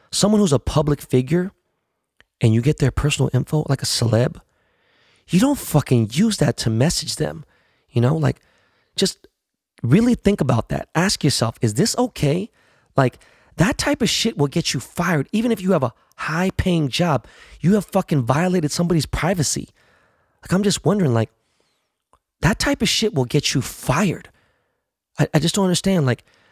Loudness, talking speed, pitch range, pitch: -20 LUFS, 175 wpm, 130-190 Hz, 155 Hz